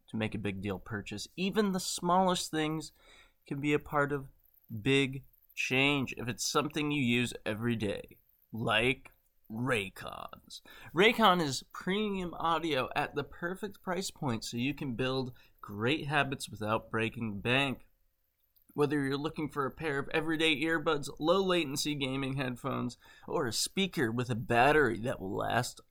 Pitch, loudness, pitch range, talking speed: 140 Hz, -32 LUFS, 115-160 Hz, 155 wpm